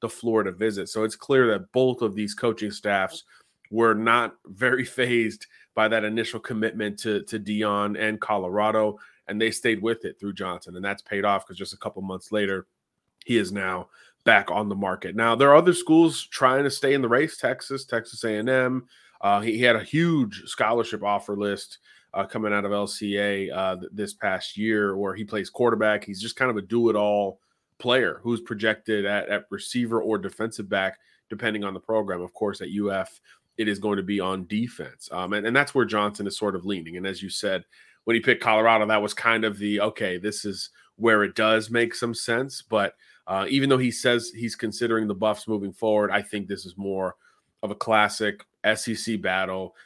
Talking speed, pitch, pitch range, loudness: 205 wpm, 110 Hz, 100-115 Hz, -25 LUFS